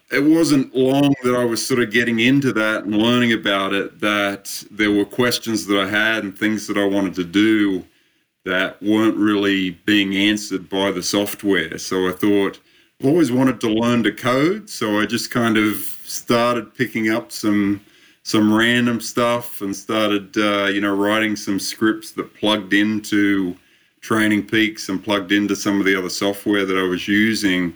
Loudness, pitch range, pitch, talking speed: -19 LUFS, 100-115 Hz, 105 Hz, 180 wpm